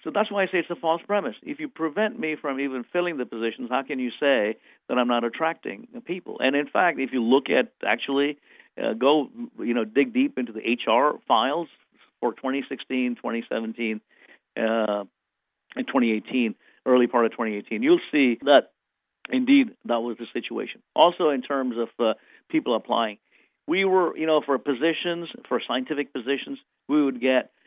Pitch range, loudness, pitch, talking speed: 120-175 Hz, -24 LUFS, 140 Hz, 180 wpm